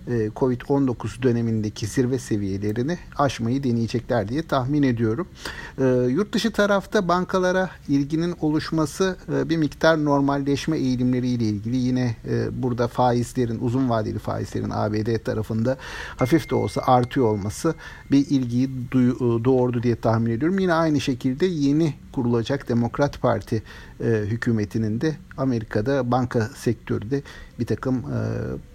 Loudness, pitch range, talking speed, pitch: -23 LUFS, 115-140 Hz, 125 wpm, 125 Hz